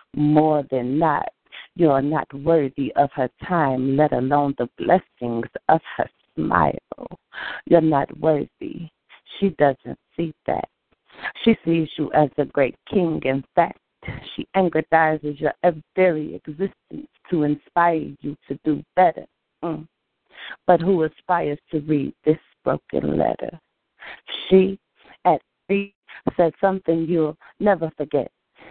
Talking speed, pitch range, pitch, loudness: 125 wpm, 145-175 Hz, 155 Hz, -22 LUFS